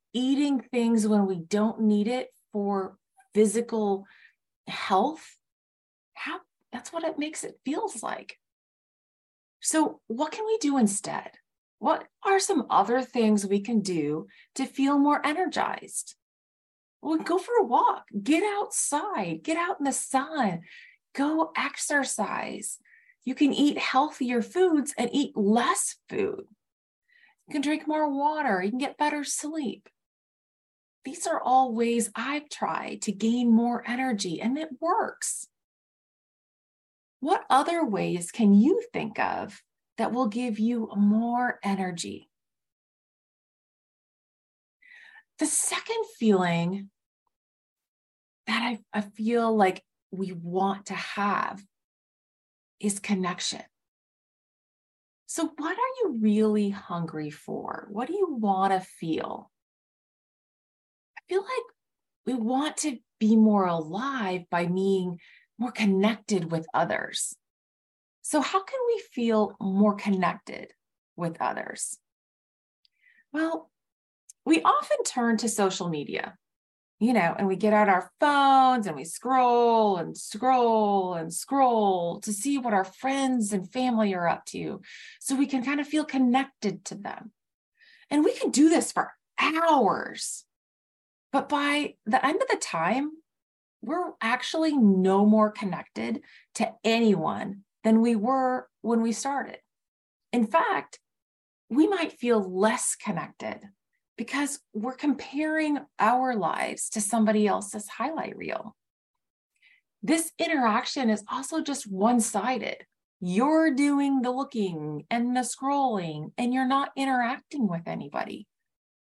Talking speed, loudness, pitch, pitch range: 125 wpm, -26 LUFS, 250 Hz, 210-300 Hz